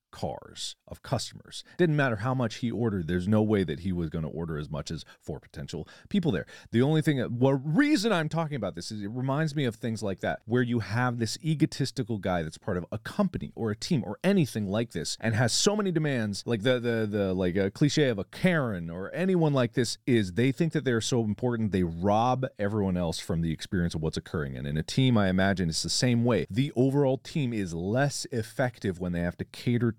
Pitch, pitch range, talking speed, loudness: 115 Hz, 95-135 Hz, 235 wpm, -28 LUFS